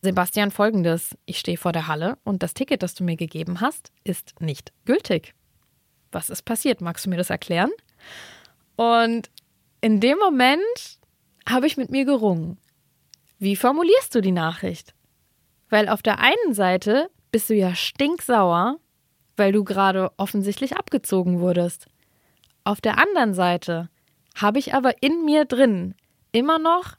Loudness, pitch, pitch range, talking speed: -21 LUFS, 210 Hz, 180-260 Hz, 150 wpm